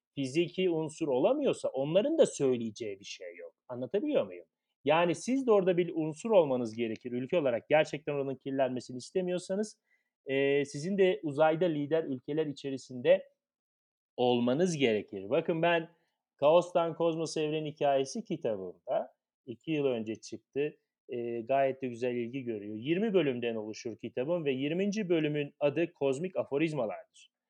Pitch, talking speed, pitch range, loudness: 150 Hz, 135 wpm, 130-180 Hz, -31 LUFS